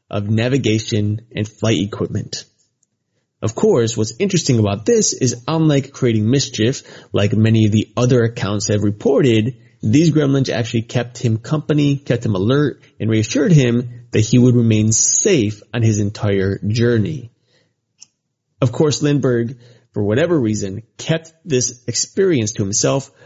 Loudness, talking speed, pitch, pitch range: -17 LUFS, 140 wpm, 120 Hz, 110-135 Hz